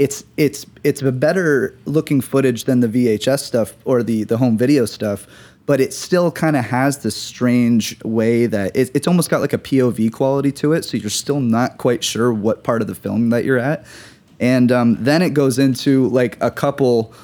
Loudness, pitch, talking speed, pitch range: -17 LUFS, 125 Hz, 210 wpm, 115-140 Hz